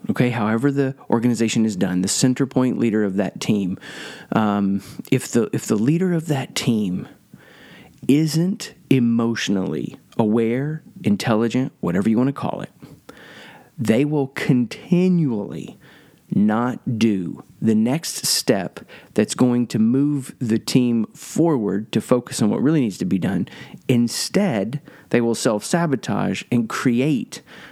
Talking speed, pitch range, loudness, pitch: 135 wpm, 110-140 Hz, -20 LUFS, 120 Hz